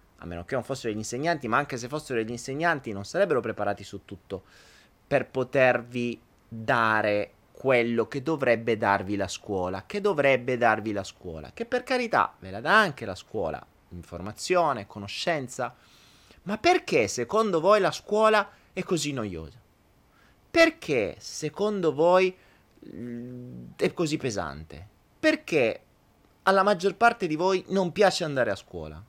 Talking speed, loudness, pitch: 140 wpm, -26 LUFS, 125 Hz